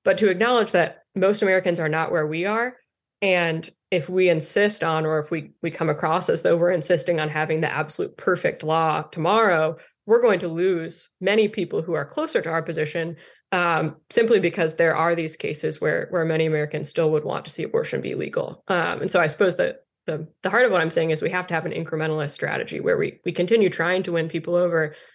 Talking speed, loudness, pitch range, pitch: 225 wpm, -22 LUFS, 160-190 Hz, 170 Hz